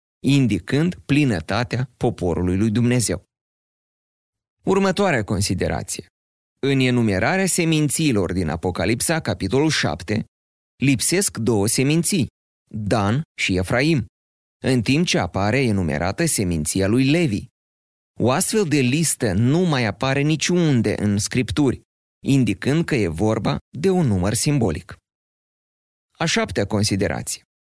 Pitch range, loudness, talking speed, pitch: 95-145 Hz, -20 LUFS, 105 wpm, 115 Hz